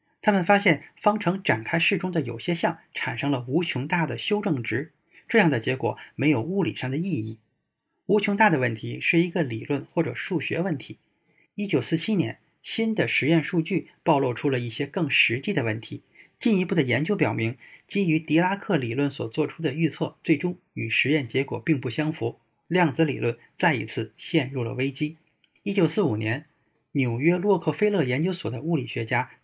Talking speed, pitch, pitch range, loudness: 285 characters per minute, 155 Hz, 130-175 Hz, -25 LUFS